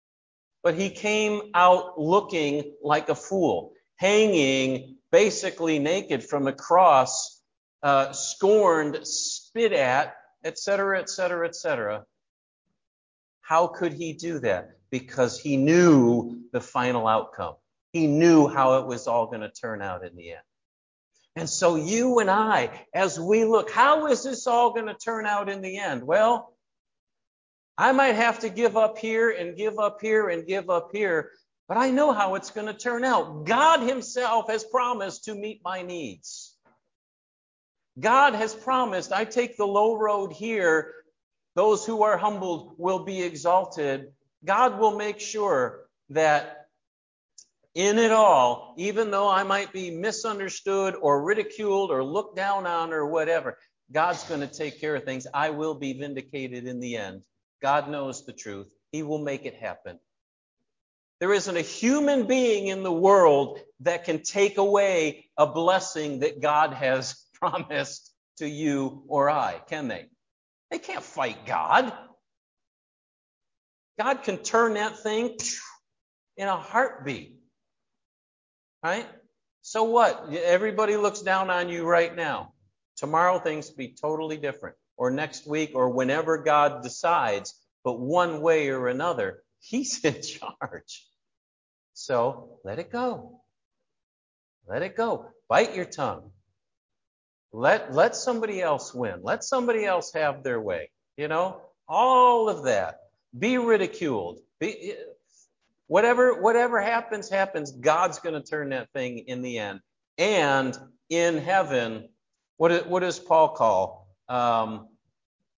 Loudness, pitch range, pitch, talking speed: -24 LUFS, 145-215 Hz, 180 Hz, 145 wpm